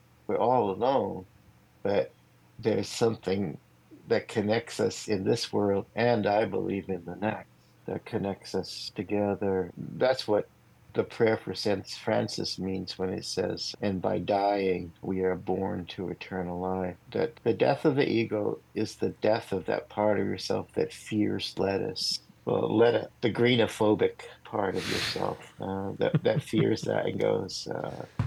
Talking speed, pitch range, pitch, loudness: 155 wpm, 95-105 Hz, 100 Hz, -29 LUFS